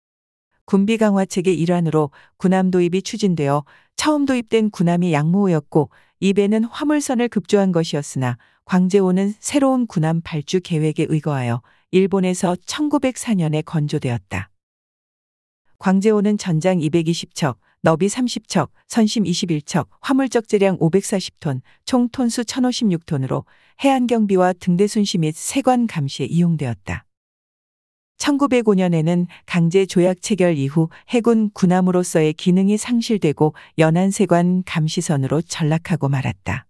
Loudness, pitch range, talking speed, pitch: -19 LUFS, 155-210 Hz, 265 characters per minute, 180 Hz